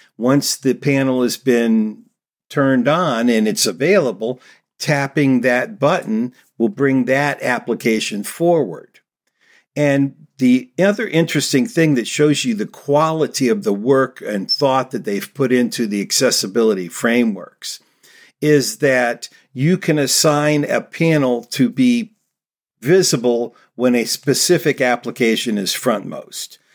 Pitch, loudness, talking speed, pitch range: 140 Hz, -17 LUFS, 125 wpm, 125-165 Hz